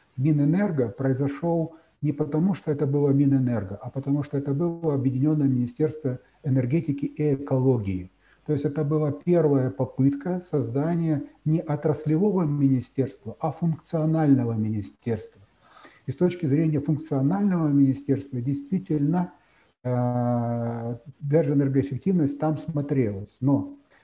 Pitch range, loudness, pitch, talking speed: 130-155 Hz, -25 LUFS, 145 Hz, 105 wpm